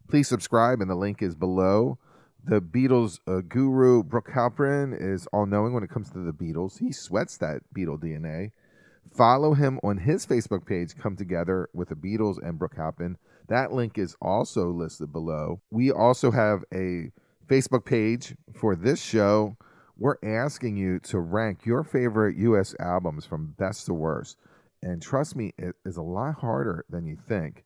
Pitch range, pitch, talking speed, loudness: 90-120 Hz, 105 Hz, 175 wpm, -26 LUFS